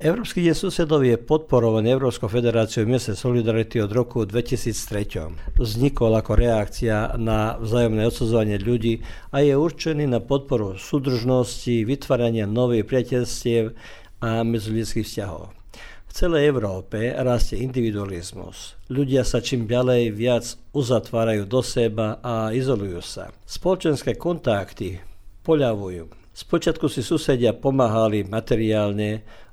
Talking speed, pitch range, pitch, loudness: 110 wpm, 110-130 Hz, 115 Hz, -22 LUFS